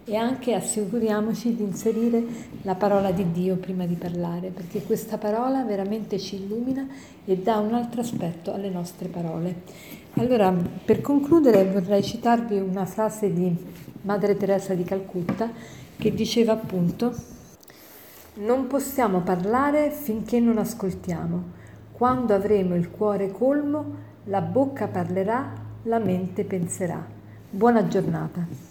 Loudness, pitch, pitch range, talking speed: -25 LUFS, 200 Hz, 185-230 Hz, 125 wpm